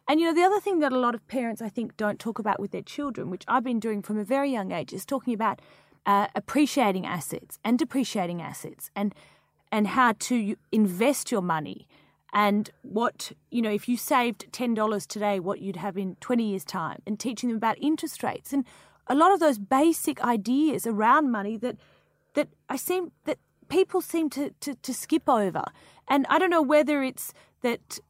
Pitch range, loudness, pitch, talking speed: 210-280 Hz, -26 LUFS, 240 Hz, 205 wpm